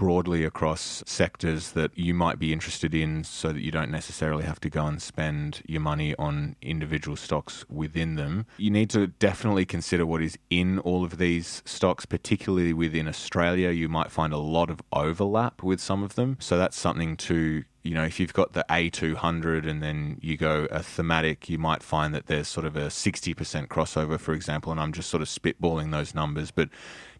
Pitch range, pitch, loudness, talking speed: 80-85 Hz, 80 Hz, -27 LUFS, 200 wpm